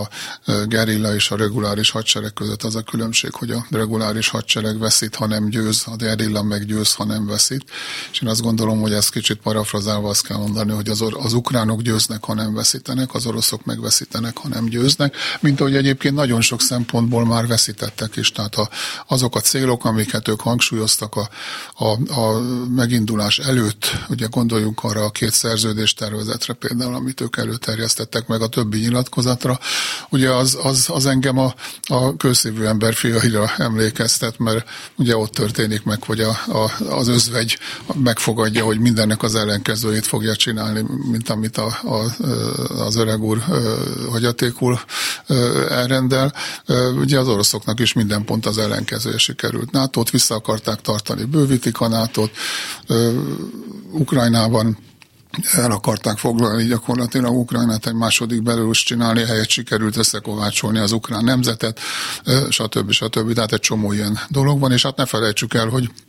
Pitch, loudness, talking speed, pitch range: 115 Hz, -18 LUFS, 155 wpm, 110-125 Hz